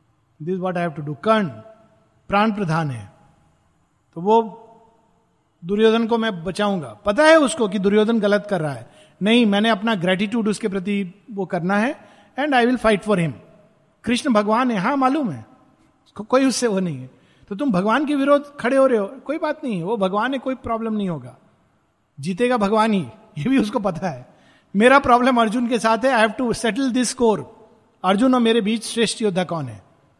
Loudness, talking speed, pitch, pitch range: -20 LUFS, 190 wpm, 215 Hz, 185-235 Hz